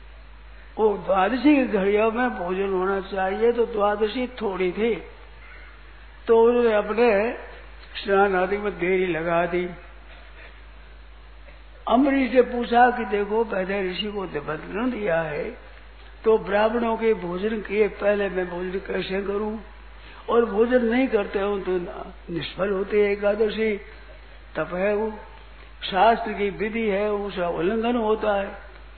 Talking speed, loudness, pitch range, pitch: 130 wpm, -23 LUFS, 185-225 Hz, 205 Hz